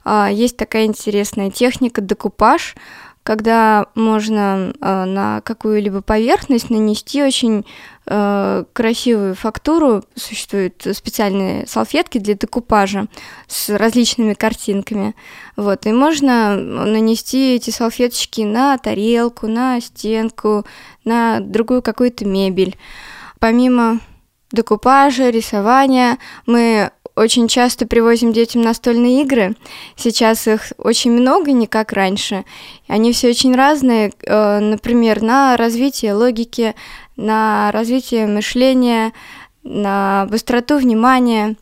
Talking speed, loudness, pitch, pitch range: 95 wpm, -15 LUFS, 225 Hz, 210-245 Hz